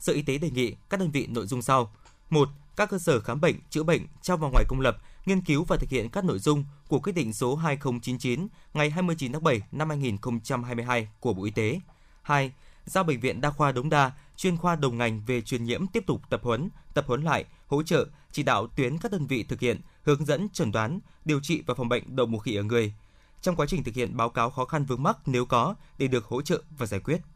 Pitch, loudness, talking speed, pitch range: 140 Hz, -28 LUFS, 250 wpm, 120-160 Hz